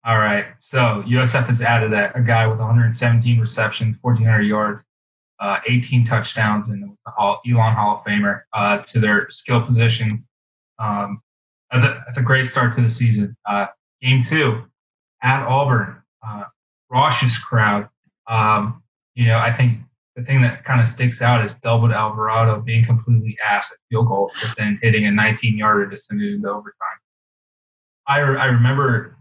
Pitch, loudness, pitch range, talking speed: 115 Hz, -18 LUFS, 110-125 Hz, 165 wpm